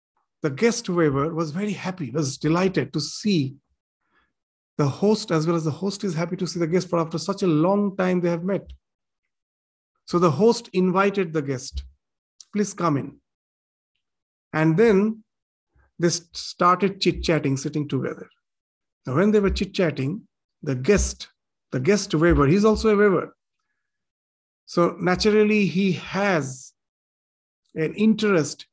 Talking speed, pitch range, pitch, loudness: 145 wpm, 145-200 Hz, 175 Hz, -22 LUFS